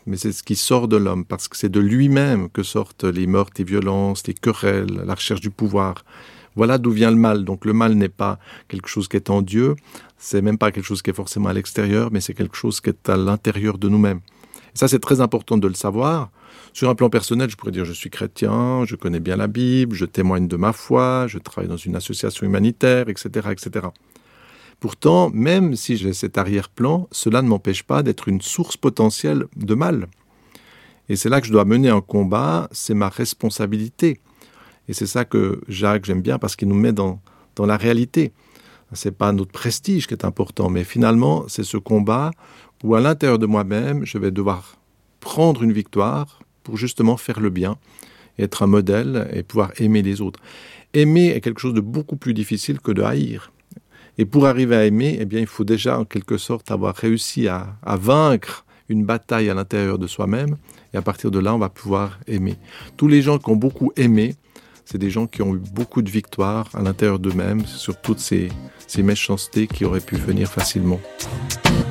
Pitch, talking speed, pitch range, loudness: 105 Hz, 210 wpm, 100-120 Hz, -19 LUFS